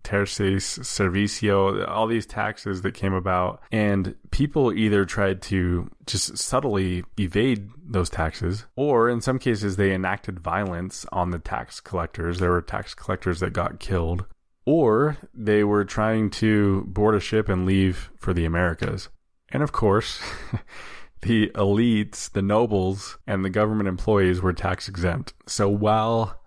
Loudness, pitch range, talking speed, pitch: -24 LUFS, 90-110 Hz, 145 wpm, 100 Hz